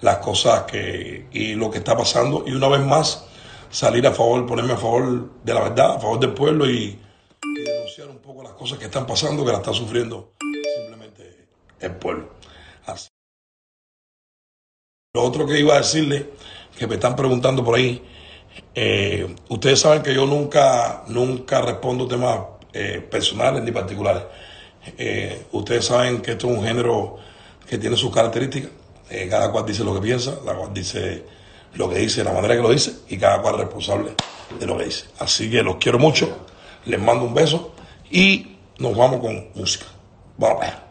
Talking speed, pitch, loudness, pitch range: 180 wpm, 125 Hz, -20 LUFS, 115-140 Hz